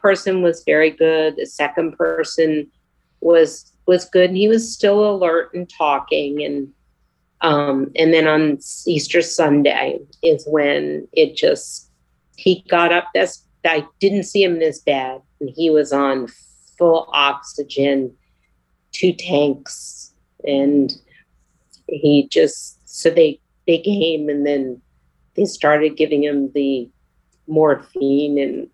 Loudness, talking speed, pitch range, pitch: -17 LUFS, 130 wpm, 140-170 Hz, 150 Hz